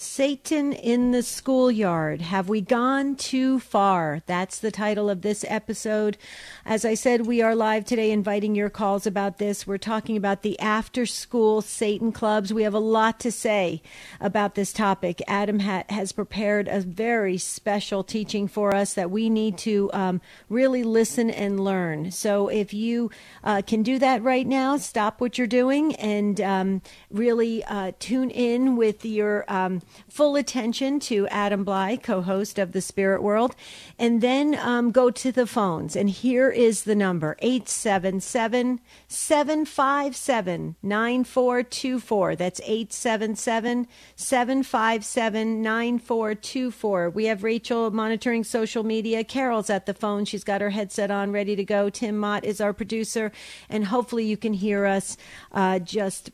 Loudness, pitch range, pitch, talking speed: -24 LUFS, 200-240 Hz, 215 Hz, 155 wpm